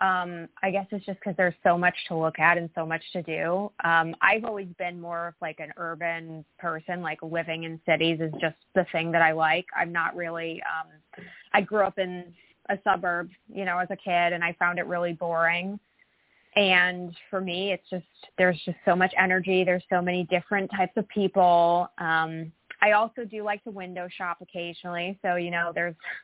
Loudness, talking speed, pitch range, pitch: -26 LUFS, 205 wpm, 165-190 Hz, 175 Hz